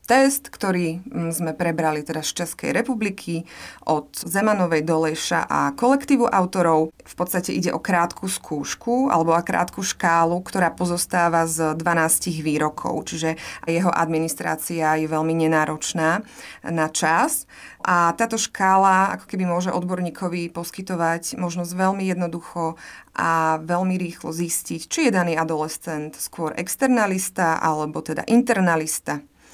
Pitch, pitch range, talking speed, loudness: 170 Hz, 160-190 Hz, 125 wpm, -22 LUFS